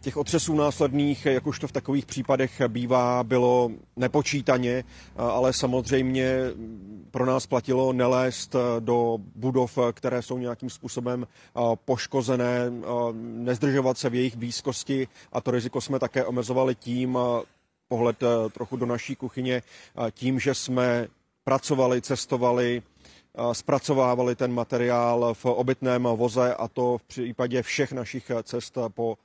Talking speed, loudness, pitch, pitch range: 125 wpm, -26 LUFS, 125 Hz, 120-130 Hz